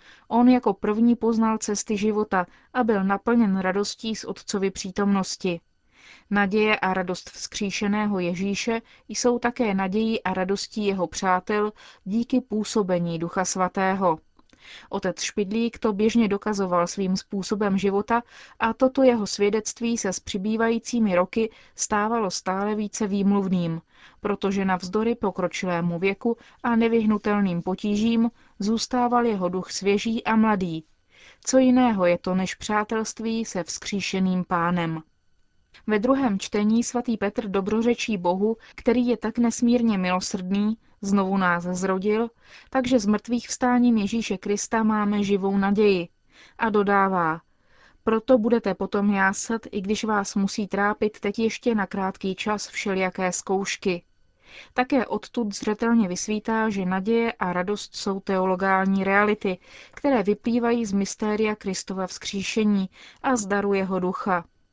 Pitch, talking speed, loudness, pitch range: 205 Hz, 125 wpm, -24 LUFS, 190-225 Hz